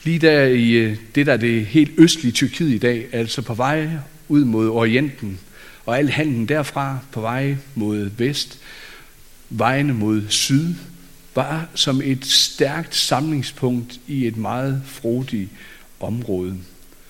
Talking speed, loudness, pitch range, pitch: 135 wpm, -19 LUFS, 115-145 Hz, 130 Hz